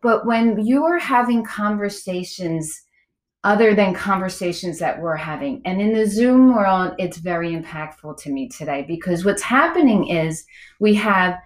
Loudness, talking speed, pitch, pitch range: -19 LUFS, 150 wpm, 190 Hz, 170-220 Hz